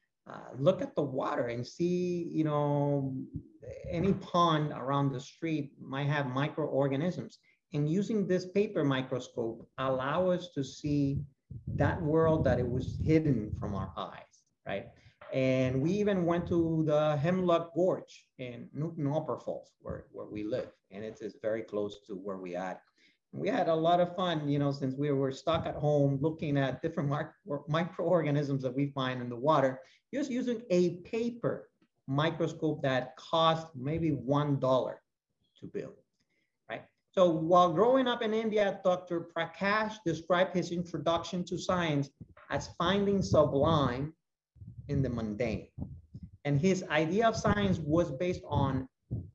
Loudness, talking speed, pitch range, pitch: -31 LUFS, 155 wpm, 135-175 Hz, 150 Hz